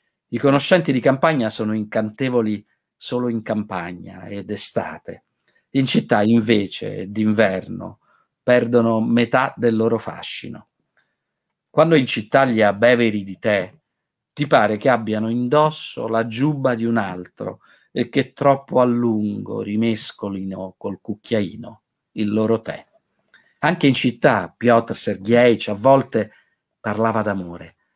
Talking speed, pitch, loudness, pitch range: 120 wpm, 115 Hz, -19 LUFS, 105-125 Hz